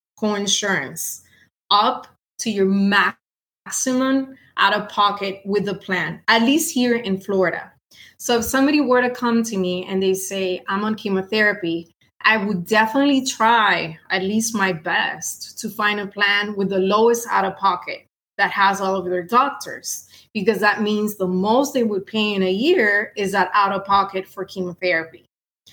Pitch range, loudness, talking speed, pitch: 190-225 Hz, -19 LUFS, 170 wpm, 205 Hz